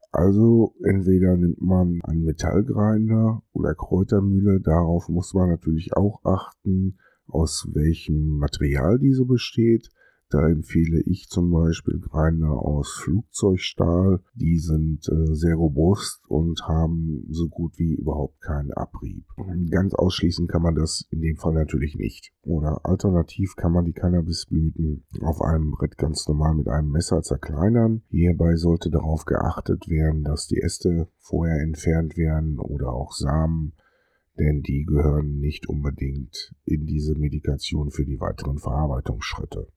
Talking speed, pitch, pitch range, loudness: 135 wpm, 80 Hz, 75-90 Hz, -23 LUFS